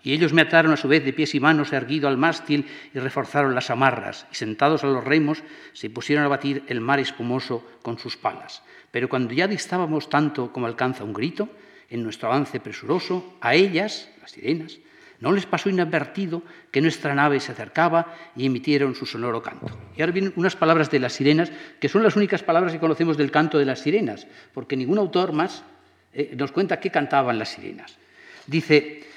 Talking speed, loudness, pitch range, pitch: 195 wpm, -22 LUFS, 135-170 Hz, 150 Hz